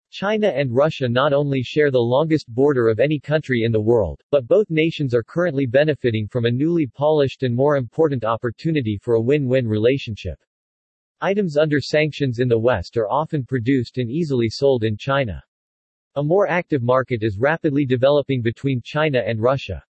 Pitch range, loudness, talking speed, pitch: 120-150 Hz, -20 LUFS, 180 wpm, 135 Hz